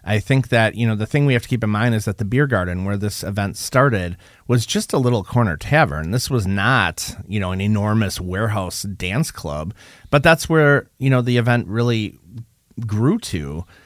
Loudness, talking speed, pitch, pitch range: -19 LUFS, 210 wpm, 110 Hz, 100-125 Hz